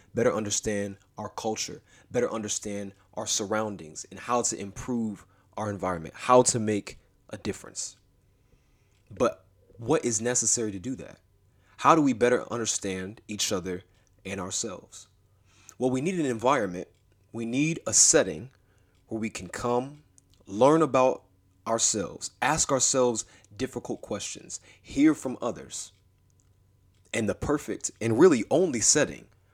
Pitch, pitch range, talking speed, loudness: 105 Hz, 95-120 Hz, 130 wpm, -26 LUFS